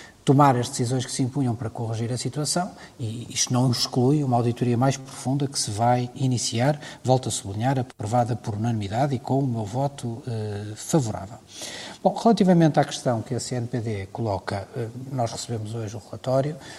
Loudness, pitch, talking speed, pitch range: -24 LUFS, 125 Hz, 175 wpm, 115-135 Hz